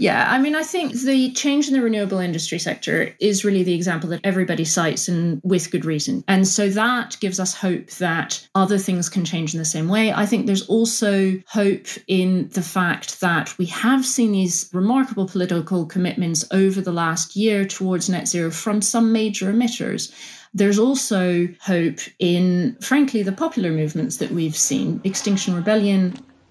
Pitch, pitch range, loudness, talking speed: 190 Hz, 175-220 Hz, -20 LUFS, 175 wpm